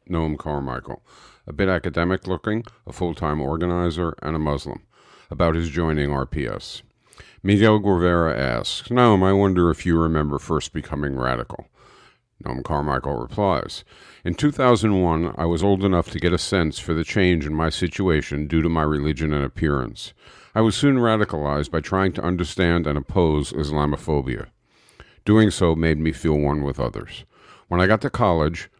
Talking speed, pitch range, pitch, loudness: 165 wpm, 75-95 Hz, 80 Hz, -21 LUFS